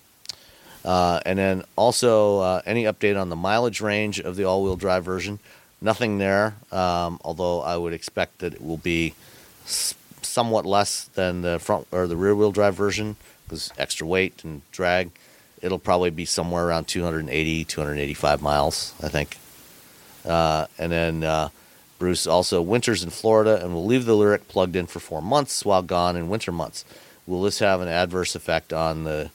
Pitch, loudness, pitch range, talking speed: 90 Hz, -23 LUFS, 85-100 Hz, 175 wpm